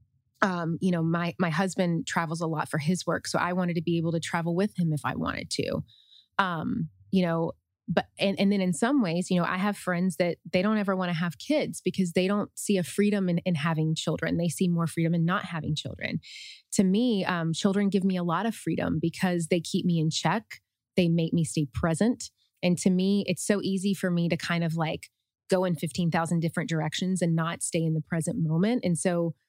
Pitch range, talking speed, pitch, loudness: 165-190 Hz, 235 wpm, 175 Hz, -27 LUFS